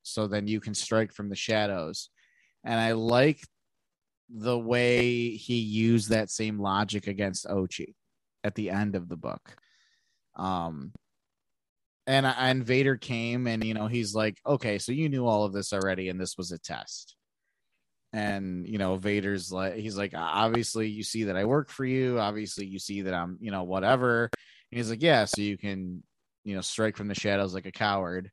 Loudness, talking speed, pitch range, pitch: -29 LUFS, 185 wpm, 100-115 Hz, 105 Hz